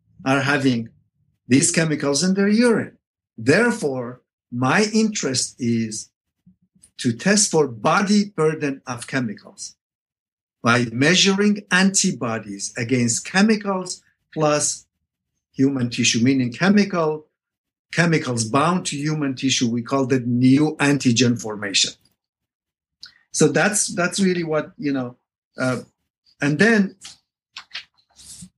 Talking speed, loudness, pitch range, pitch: 105 wpm, -19 LUFS, 125-185 Hz, 145 Hz